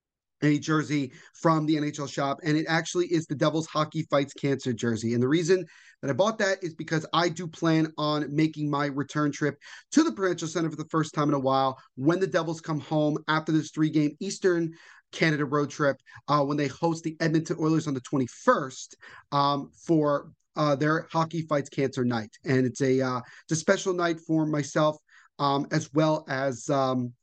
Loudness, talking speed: -27 LUFS, 195 wpm